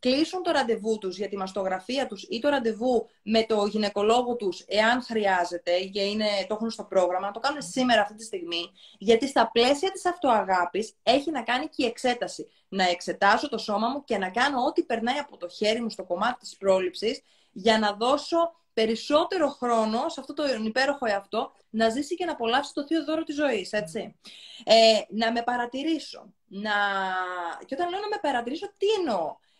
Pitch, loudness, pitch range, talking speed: 225 Hz, -26 LUFS, 205-275 Hz, 190 wpm